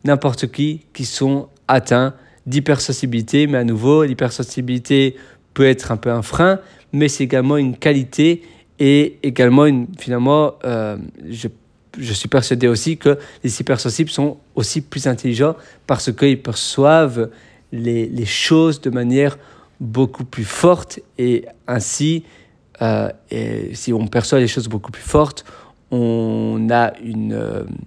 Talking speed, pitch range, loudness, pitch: 140 wpm, 120-145 Hz, -17 LUFS, 130 Hz